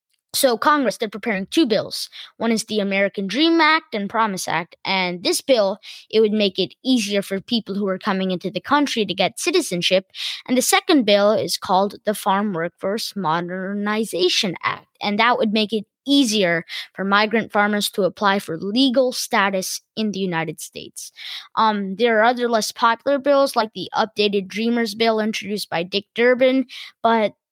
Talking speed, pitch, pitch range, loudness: 175 wpm, 210 Hz, 195-235 Hz, -20 LUFS